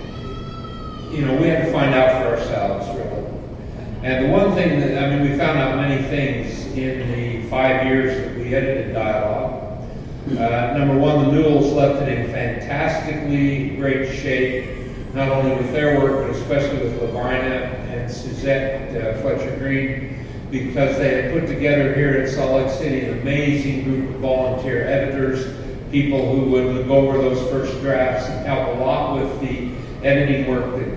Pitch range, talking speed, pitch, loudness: 130-140 Hz, 170 wpm, 135 Hz, -20 LUFS